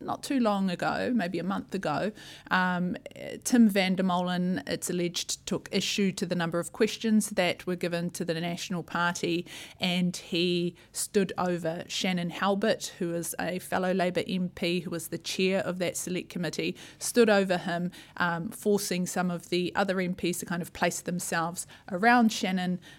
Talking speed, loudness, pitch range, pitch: 170 wpm, -29 LUFS, 175-195 Hz, 180 Hz